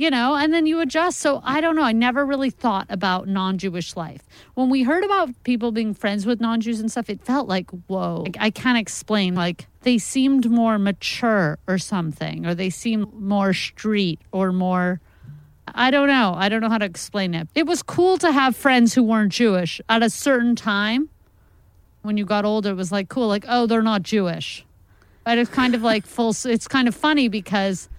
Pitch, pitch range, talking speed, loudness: 215 Hz, 185-250 Hz, 210 wpm, -21 LUFS